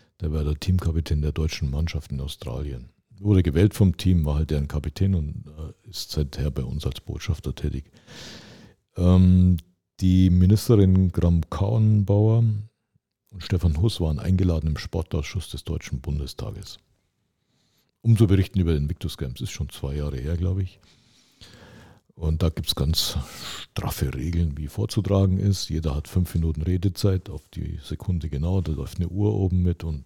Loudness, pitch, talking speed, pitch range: -24 LUFS, 90 Hz, 160 wpm, 75-100 Hz